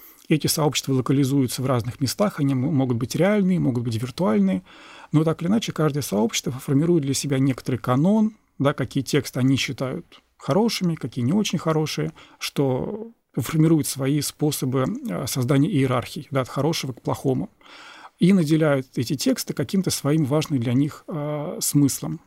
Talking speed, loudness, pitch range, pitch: 150 wpm, -23 LUFS, 135-165 Hz, 145 Hz